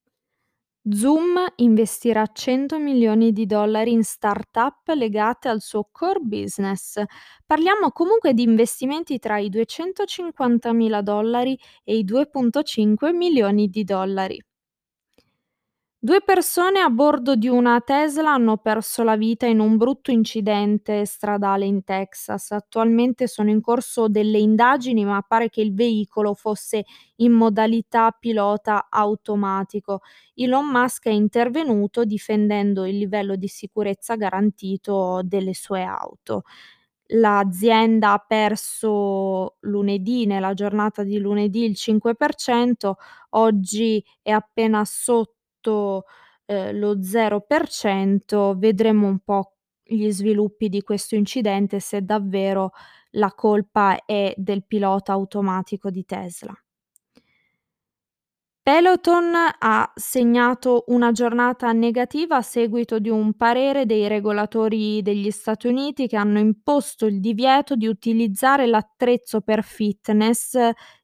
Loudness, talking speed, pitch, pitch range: -20 LUFS, 115 wpm, 220 Hz, 205-240 Hz